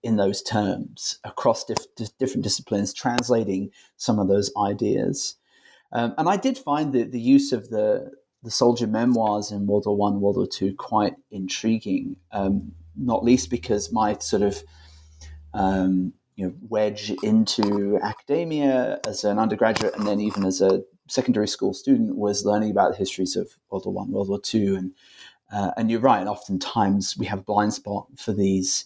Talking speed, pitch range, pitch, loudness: 175 wpm, 95-120 Hz, 105 Hz, -24 LUFS